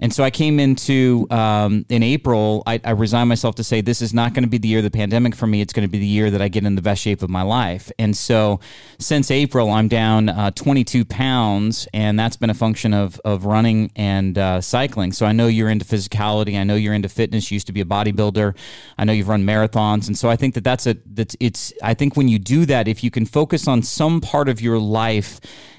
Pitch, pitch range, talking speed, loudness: 110 Hz, 105-120 Hz, 255 wpm, -18 LUFS